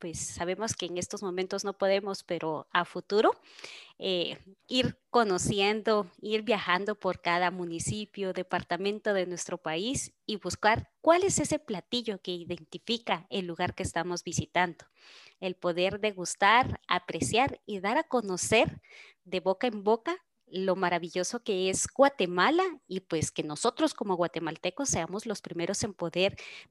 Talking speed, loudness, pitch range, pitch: 145 wpm, -30 LUFS, 175-215 Hz, 185 Hz